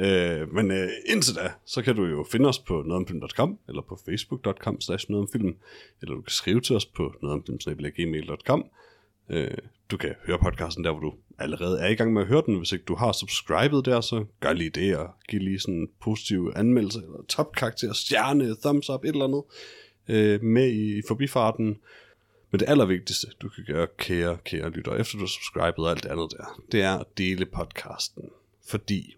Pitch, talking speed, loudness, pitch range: 100 Hz, 195 wpm, -26 LUFS, 90-115 Hz